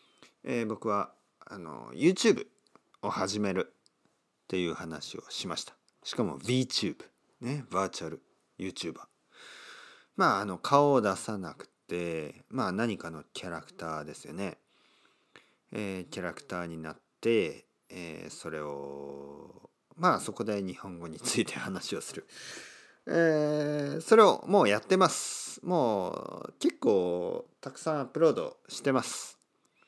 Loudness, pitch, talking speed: -30 LUFS, 110 Hz, 275 characters per minute